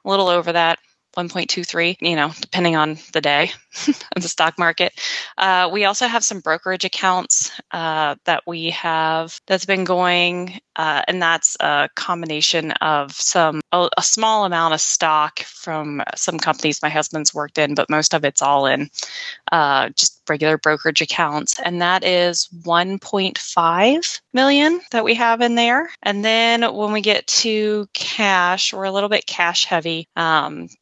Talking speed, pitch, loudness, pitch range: 165 wpm, 175 Hz, -18 LUFS, 160-200 Hz